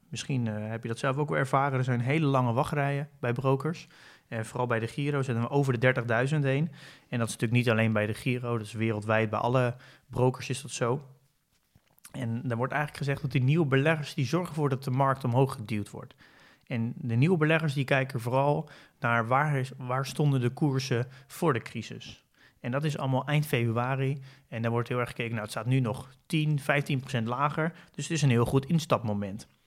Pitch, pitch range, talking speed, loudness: 130 Hz, 120-145 Hz, 215 wpm, -29 LUFS